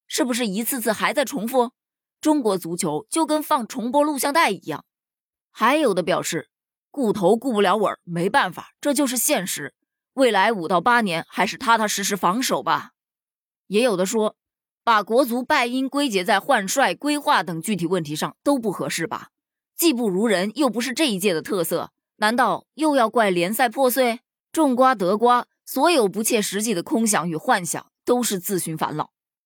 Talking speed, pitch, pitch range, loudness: 265 characters per minute, 240 Hz, 200-275 Hz, -21 LUFS